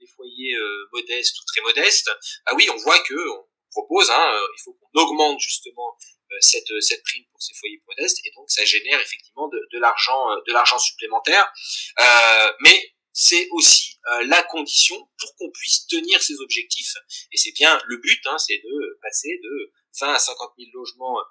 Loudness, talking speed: -16 LUFS, 190 wpm